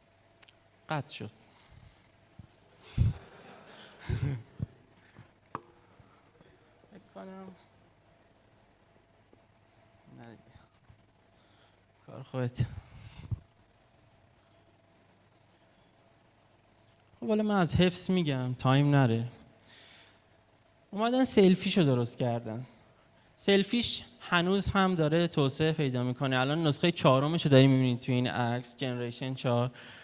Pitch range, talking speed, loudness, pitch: 110-135 Hz, 70 wpm, -29 LUFS, 115 Hz